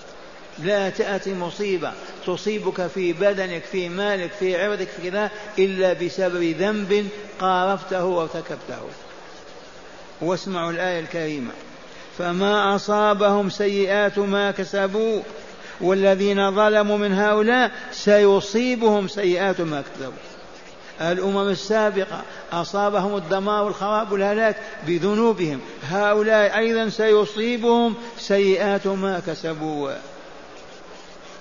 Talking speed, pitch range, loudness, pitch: 90 wpm, 185-210 Hz, -21 LUFS, 200 Hz